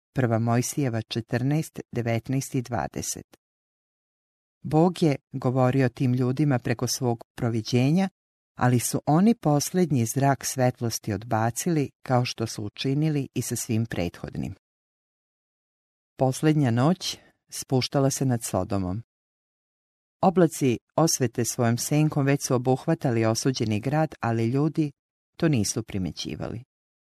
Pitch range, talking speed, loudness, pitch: 115-145 Hz, 100 wpm, -25 LUFS, 130 Hz